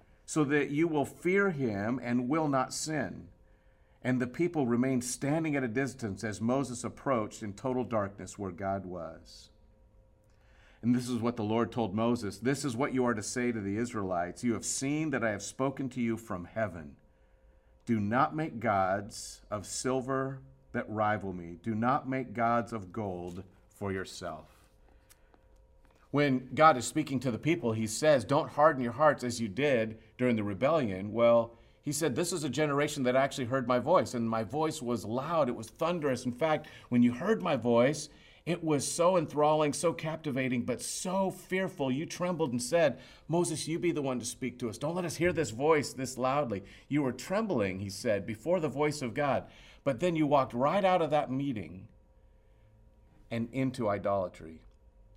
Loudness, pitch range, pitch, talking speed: -31 LUFS, 105-145 Hz, 125 Hz, 185 wpm